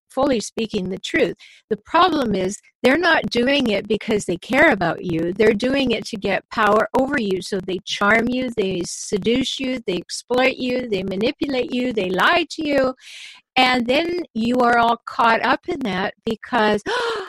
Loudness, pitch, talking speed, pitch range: -20 LUFS, 235 Hz, 175 wpm, 205-265 Hz